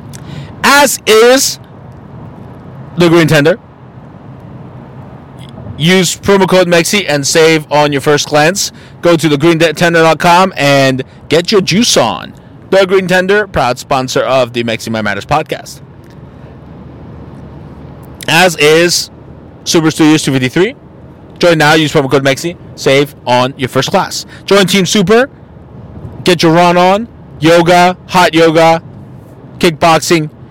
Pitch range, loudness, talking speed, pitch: 140-180 Hz, -9 LUFS, 120 wpm, 160 Hz